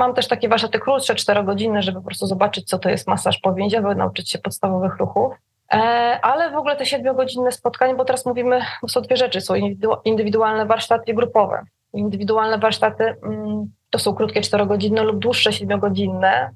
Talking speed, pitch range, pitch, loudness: 160 wpm, 200-245 Hz, 220 Hz, -19 LUFS